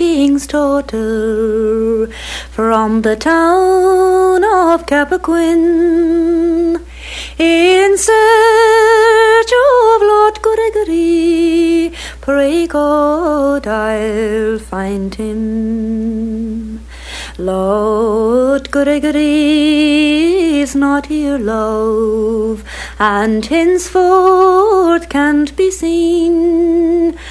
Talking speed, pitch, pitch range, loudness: 60 wpm, 300 Hz, 225-345 Hz, -12 LUFS